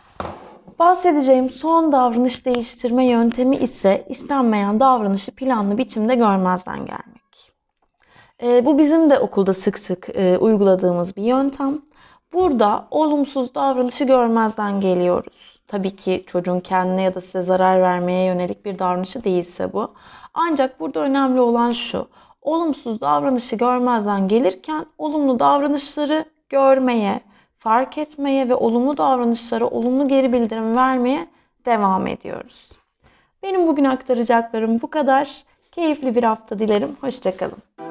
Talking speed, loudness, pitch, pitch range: 120 wpm, -19 LUFS, 245 Hz, 205-275 Hz